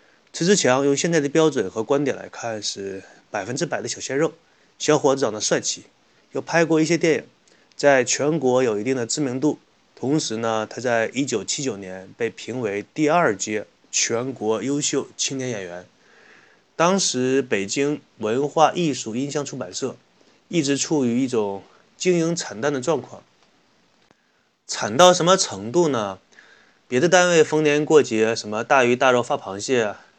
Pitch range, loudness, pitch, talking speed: 115-155 Hz, -21 LUFS, 135 Hz, 235 characters per minute